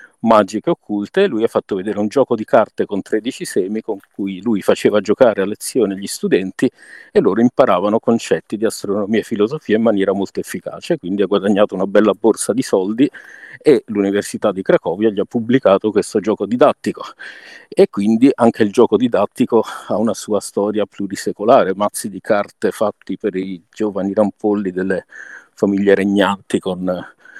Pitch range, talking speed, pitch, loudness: 95-110 Hz, 165 wpm, 100 Hz, -17 LUFS